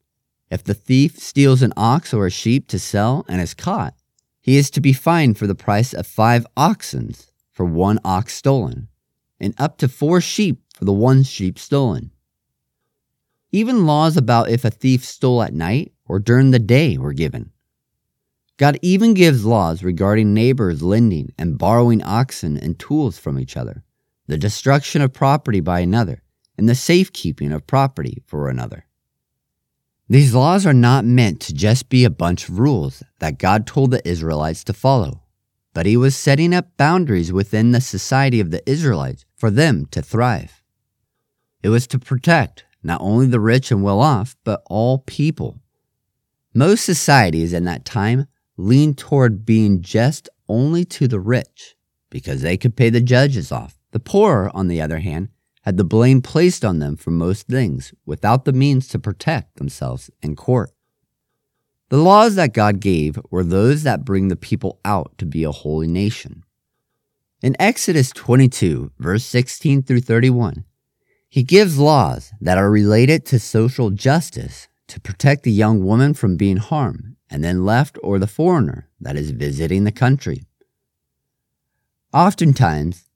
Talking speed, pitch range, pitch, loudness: 165 wpm, 95-135 Hz, 120 Hz, -17 LUFS